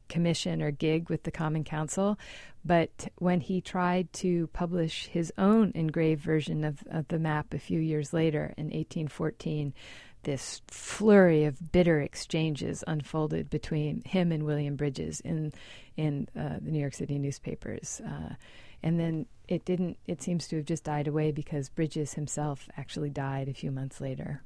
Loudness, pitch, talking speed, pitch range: -31 LUFS, 155 Hz, 165 wpm, 150-170 Hz